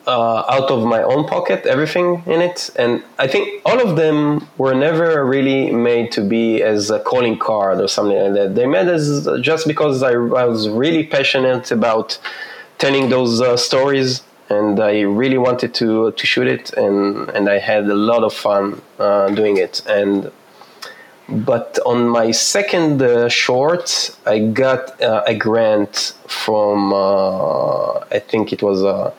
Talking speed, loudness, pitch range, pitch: 170 wpm, -16 LUFS, 105-135 Hz, 120 Hz